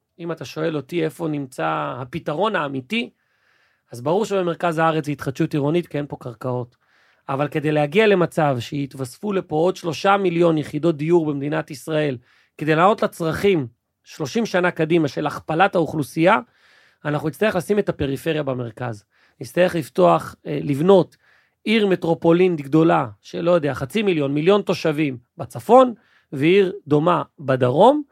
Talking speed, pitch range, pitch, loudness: 135 wpm, 145-180 Hz, 160 Hz, -20 LUFS